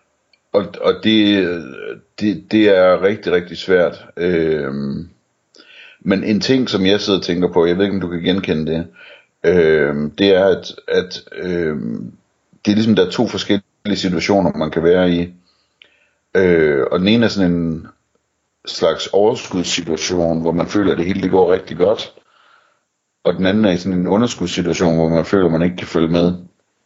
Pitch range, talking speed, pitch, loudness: 85-100 Hz, 180 wpm, 90 Hz, -16 LUFS